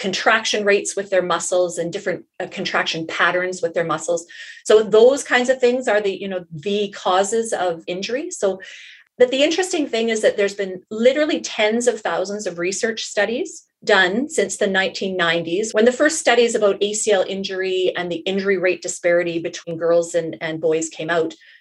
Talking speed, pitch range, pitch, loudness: 180 wpm, 180-235 Hz, 200 Hz, -19 LUFS